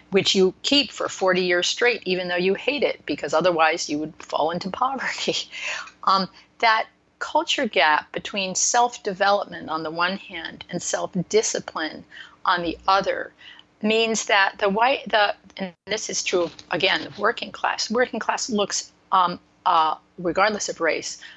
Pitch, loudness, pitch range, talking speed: 195 Hz, -22 LUFS, 180-225 Hz, 150 wpm